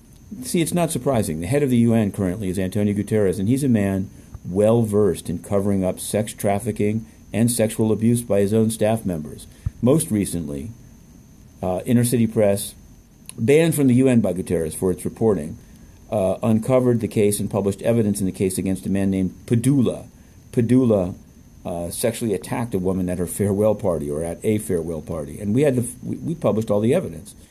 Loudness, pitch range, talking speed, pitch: -21 LUFS, 95-115 Hz, 190 wpm, 105 Hz